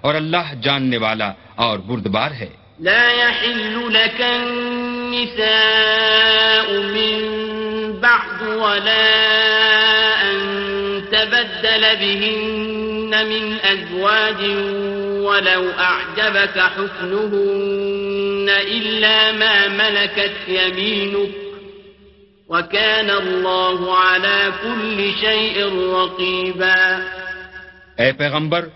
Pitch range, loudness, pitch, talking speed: 185-220 Hz, -16 LUFS, 200 Hz, 65 wpm